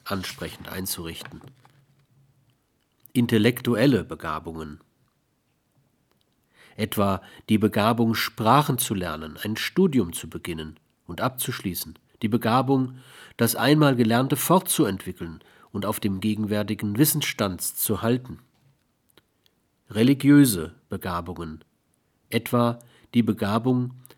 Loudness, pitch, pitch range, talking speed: -24 LUFS, 115 Hz, 95-130 Hz, 85 wpm